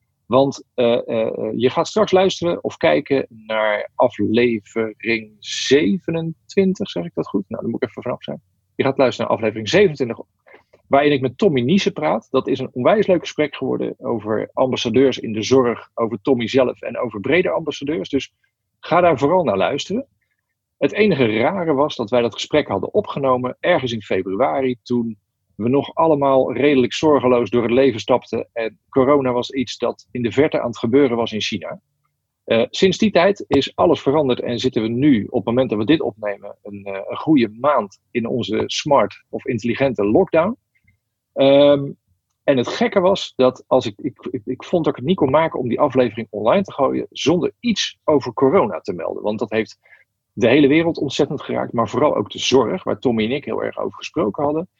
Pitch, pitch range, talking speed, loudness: 125 Hz, 110-150 Hz, 195 wpm, -19 LUFS